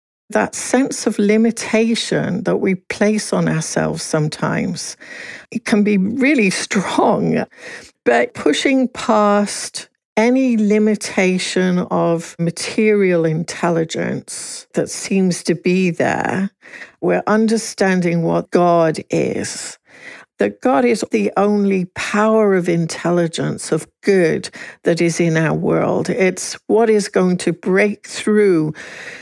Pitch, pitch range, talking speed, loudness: 195 Hz, 170-215 Hz, 115 wpm, -17 LUFS